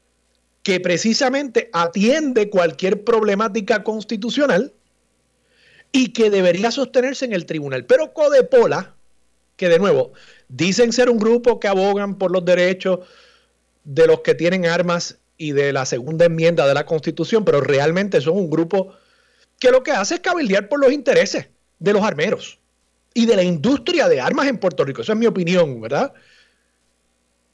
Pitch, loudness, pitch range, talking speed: 200 Hz, -18 LUFS, 170-255 Hz, 155 wpm